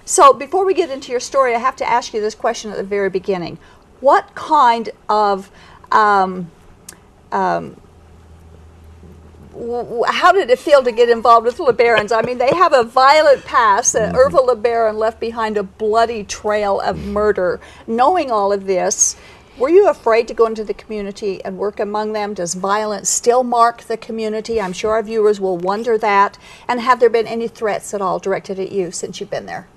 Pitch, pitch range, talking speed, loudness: 220 Hz, 200-240 Hz, 190 wpm, -16 LUFS